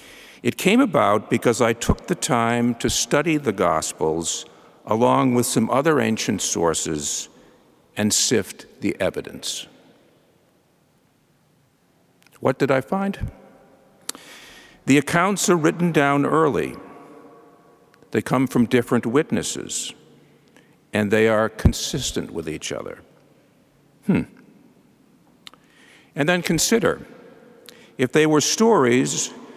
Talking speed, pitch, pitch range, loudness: 105 wpm, 140 Hz, 120-175 Hz, -21 LUFS